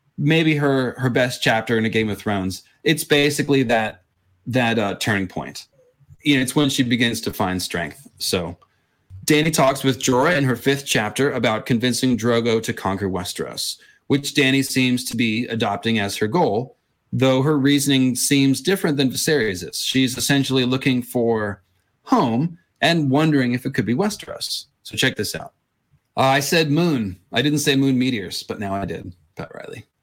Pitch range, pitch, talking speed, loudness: 115-140 Hz, 130 Hz, 175 wpm, -20 LUFS